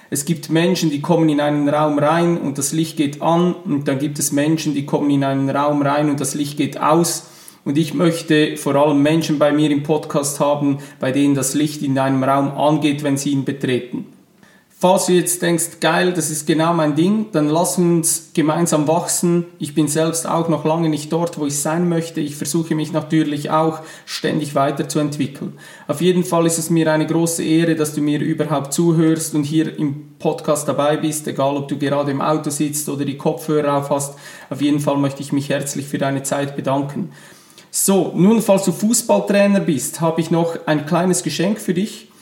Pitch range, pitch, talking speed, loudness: 145-165 Hz, 155 Hz, 205 wpm, -18 LUFS